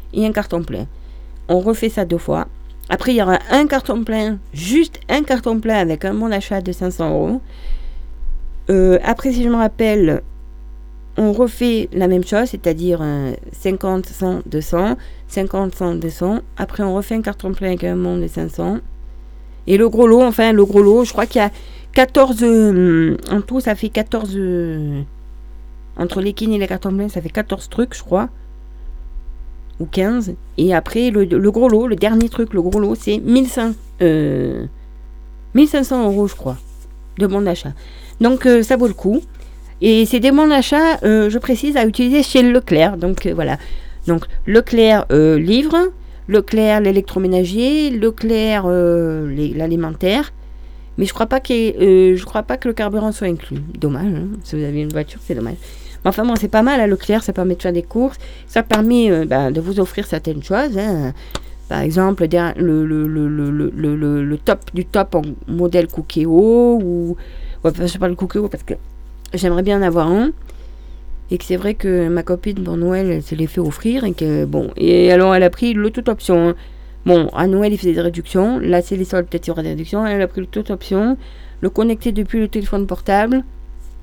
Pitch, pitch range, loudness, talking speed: 190 Hz, 160-220 Hz, -16 LUFS, 195 wpm